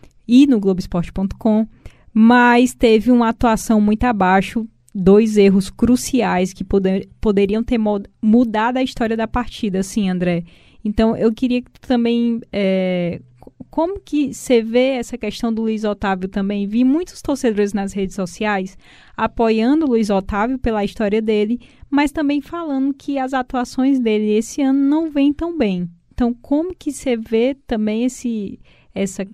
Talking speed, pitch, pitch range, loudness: 155 wpm, 225 Hz, 205-250 Hz, -18 LUFS